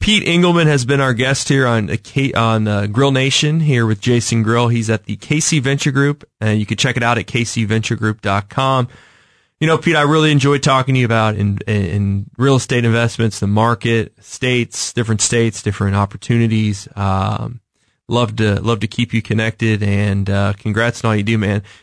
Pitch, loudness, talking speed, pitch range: 115 Hz, -16 LUFS, 185 wpm, 105-135 Hz